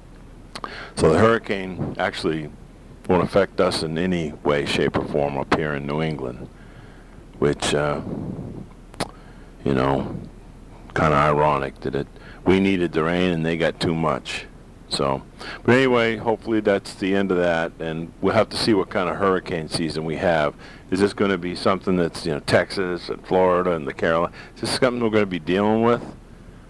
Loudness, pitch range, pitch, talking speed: -22 LUFS, 80-100 Hz, 90 Hz, 180 wpm